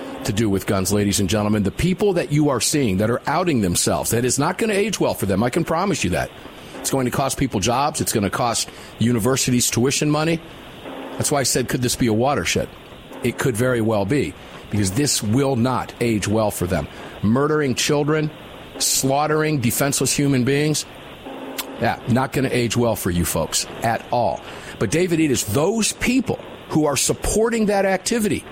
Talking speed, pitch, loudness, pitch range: 200 wpm, 135 Hz, -20 LUFS, 110-155 Hz